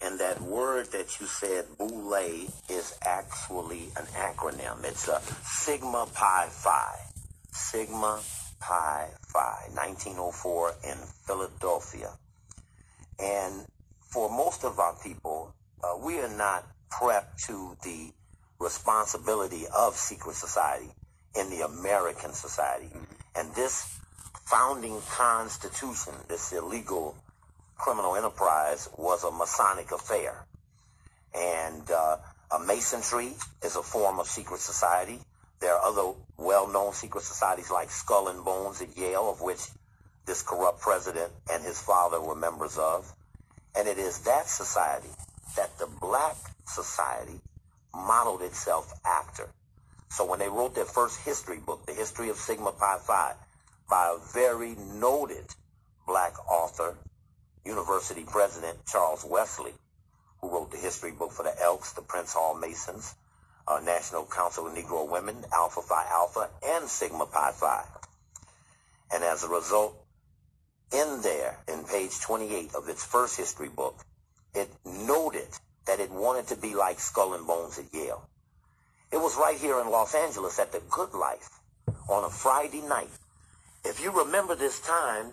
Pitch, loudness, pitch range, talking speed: 95 Hz, -30 LUFS, 85-105 Hz, 140 wpm